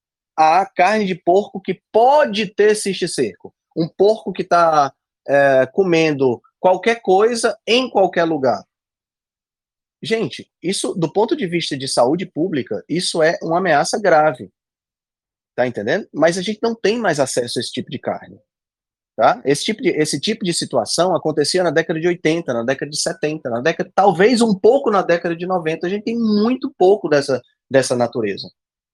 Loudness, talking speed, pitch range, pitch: -17 LUFS, 170 wpm, 155-205 Hz, 175 Hz